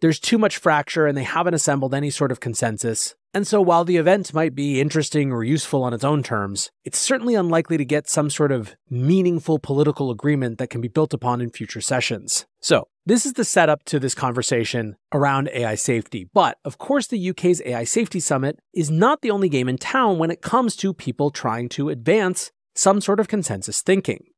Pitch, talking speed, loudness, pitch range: 150 Hz, 205 wpm, -21 LUFS, 125-180 Hz